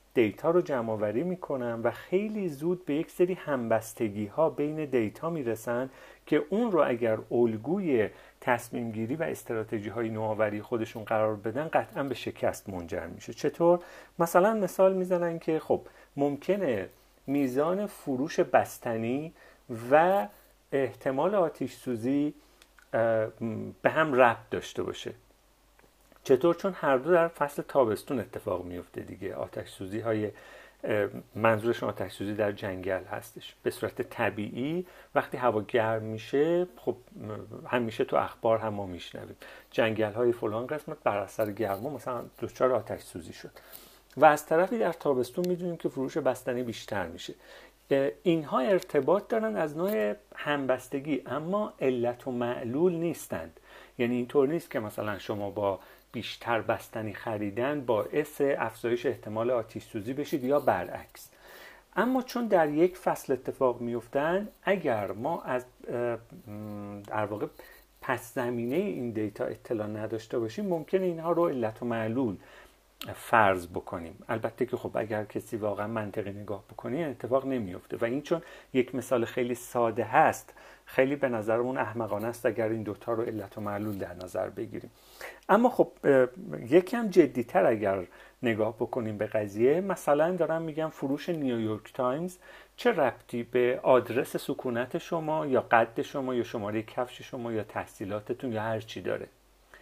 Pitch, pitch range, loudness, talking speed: 125 Hz, 110-155 Hz, -30 LUFS, 140 wpm